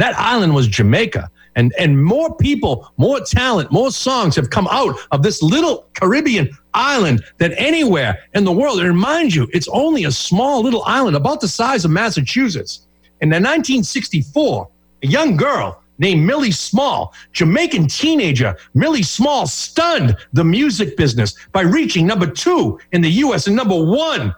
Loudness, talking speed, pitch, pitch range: -15 LUFS, 160 wpm, 175 Hz, 145-235 Hz